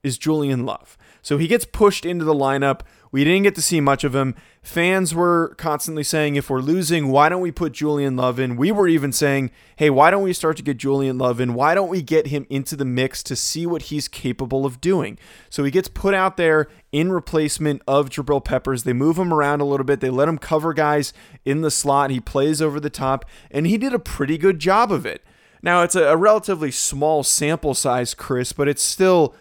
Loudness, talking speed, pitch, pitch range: -19 LUFS, 230 wpm, 150 Hz, 135-170 Hz